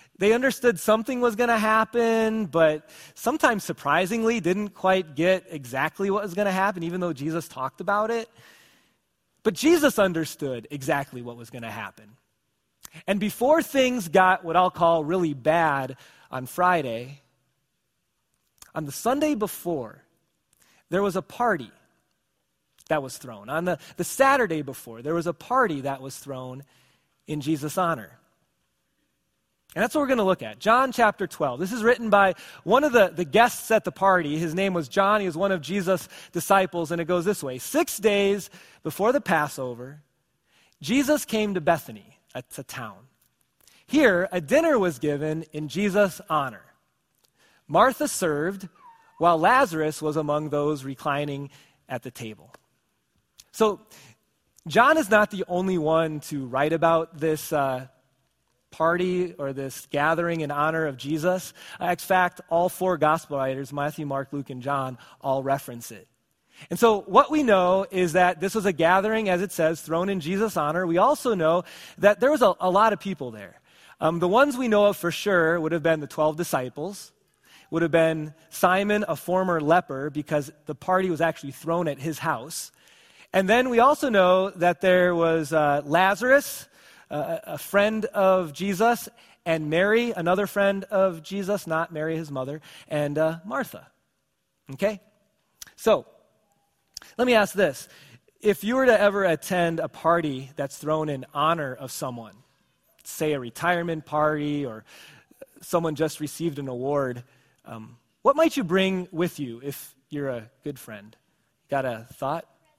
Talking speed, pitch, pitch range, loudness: 165 wpm, 170 Hz, 145-200 Hz, -24 LUFS